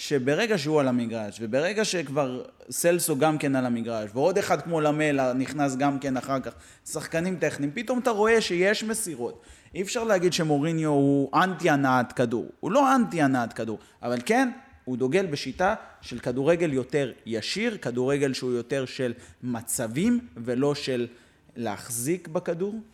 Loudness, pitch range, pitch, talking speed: -26 LUFS, 125-180 Hz, 145 Hz, 150 wpm